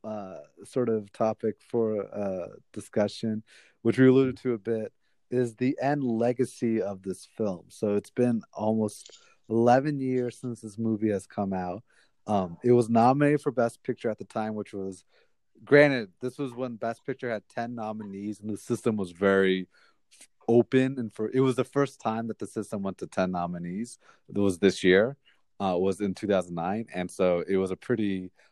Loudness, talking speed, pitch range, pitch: -28 LUFS, 185 wpm, 100-125 Hz, 110 Hz